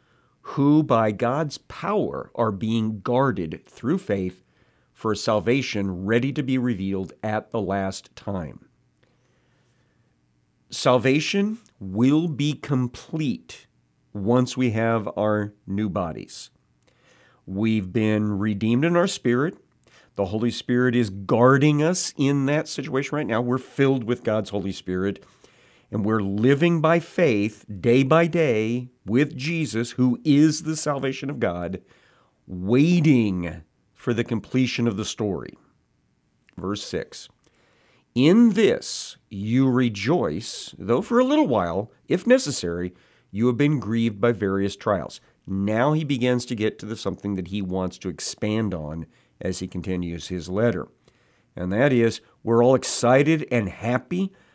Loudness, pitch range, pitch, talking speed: -23 LUFS, 100-140 Hz, 120 Hz, 135 wpm